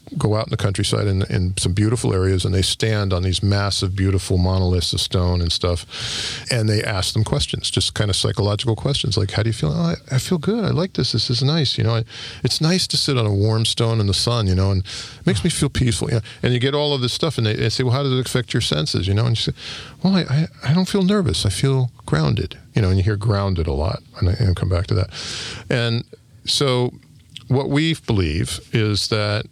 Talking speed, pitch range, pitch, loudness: 255 wpm, 100-130 Hz, 115 Hz, -20 LUFS